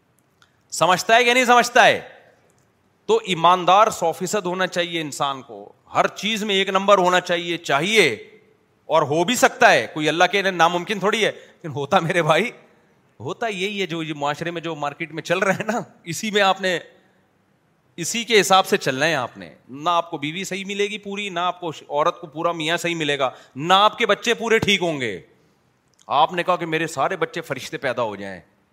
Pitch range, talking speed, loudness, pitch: 165-205 Hz, 210 wpm, -20 LUFS, 180 Hz